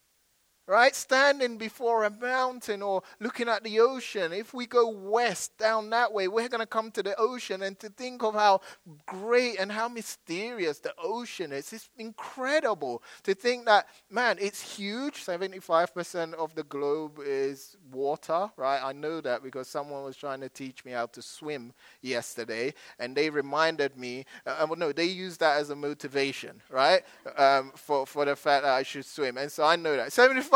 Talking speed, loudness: 185 wpm, -28 LUFS